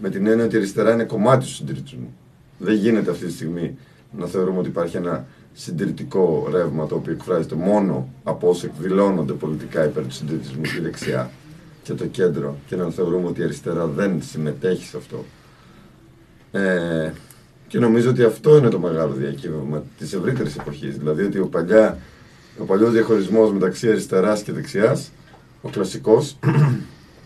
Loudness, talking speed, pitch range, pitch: -20 LUFS, 155 wpm, 75-110 Hz, 95 Hz